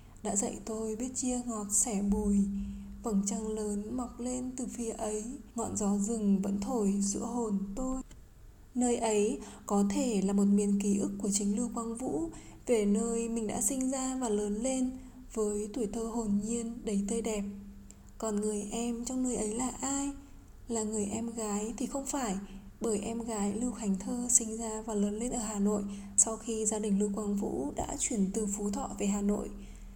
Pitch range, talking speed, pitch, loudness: 205-235 Hz, 200 wpm, 220 Hz, -32 LUFS